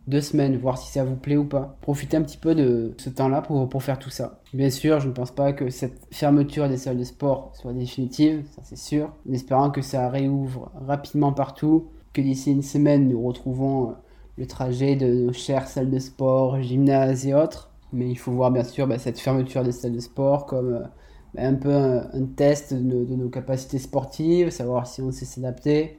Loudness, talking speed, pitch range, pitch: -24 LUFS, 215 wpm, 125-145 Hz, 135 Hz